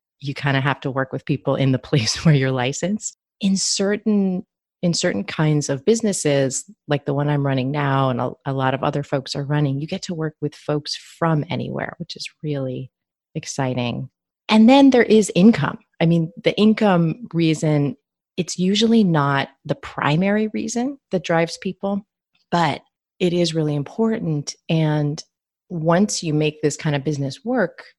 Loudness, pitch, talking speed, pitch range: -20 LUFS, 155 Hz, 175 wpm, 140-195 Hz